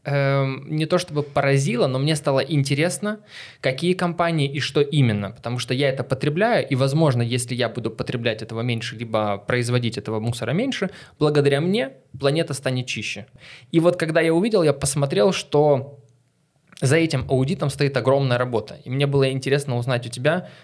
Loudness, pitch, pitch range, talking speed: -22 LUFS, 140 Hz, 125-155 Hz, 170 wpm